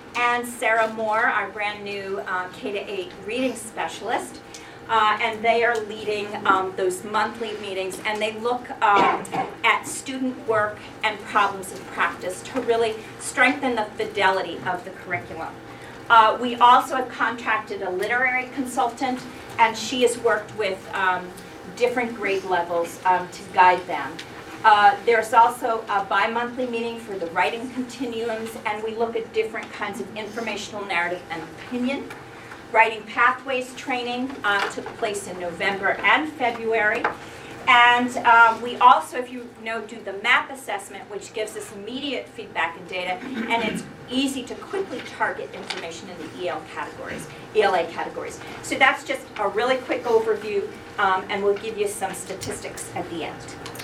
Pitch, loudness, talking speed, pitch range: 225 Hz, -23 LUFS, 155 wpm, 200-245 Hz